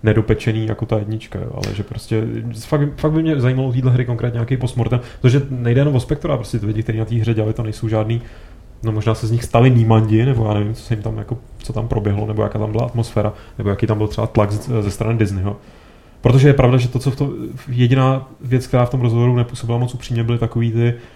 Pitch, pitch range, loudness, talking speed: 115 Hz, 110-125 Hz, -18 LUFS, 245 wpm